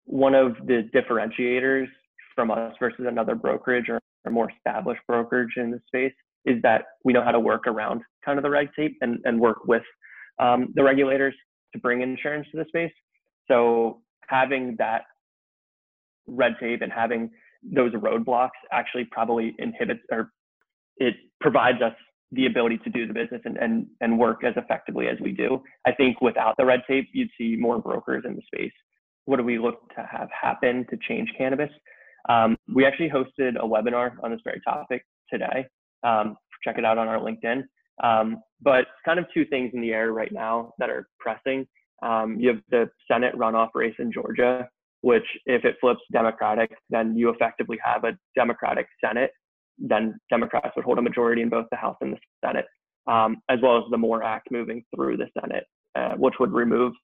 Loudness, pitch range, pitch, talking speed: -24 LUFS, 115-135 Hz, 120 Hz, 185 wpm